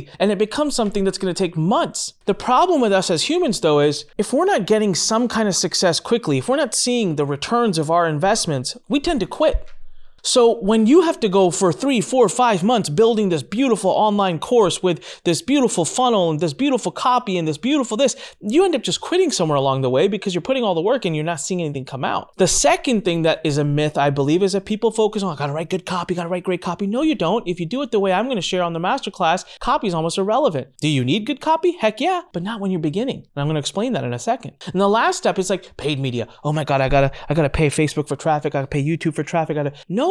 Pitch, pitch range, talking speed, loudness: 190 Hz, 160-235 Hz, 270 wpm, -19 LUFS